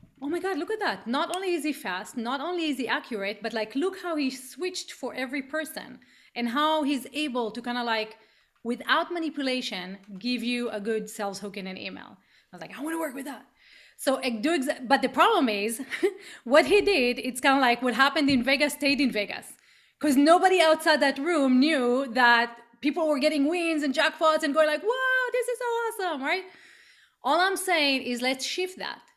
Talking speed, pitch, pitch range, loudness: 210 wpm, 280 Hz, 245-325 Hz, -26 LUFS